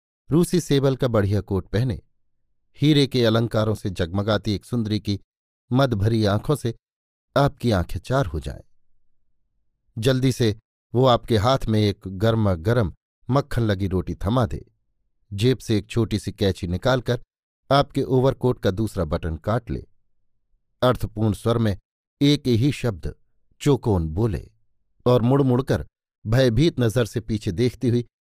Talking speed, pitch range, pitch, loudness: 145 wpm, 105-125 Hz, 115 Hz, -22 LUFS